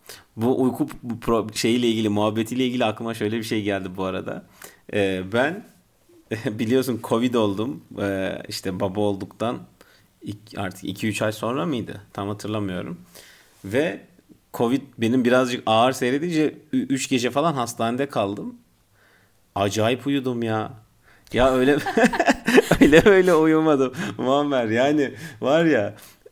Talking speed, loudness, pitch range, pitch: 120 wpm, -22 LUFS, 105-130 Hz, 115 Hz